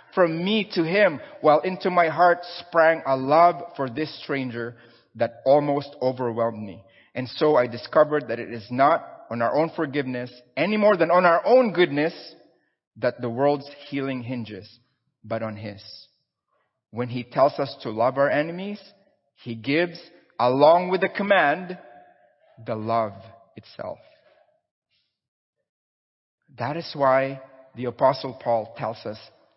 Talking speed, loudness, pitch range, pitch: 140 wpm, -23 LUFS, 120-170 Hz, 140 Hz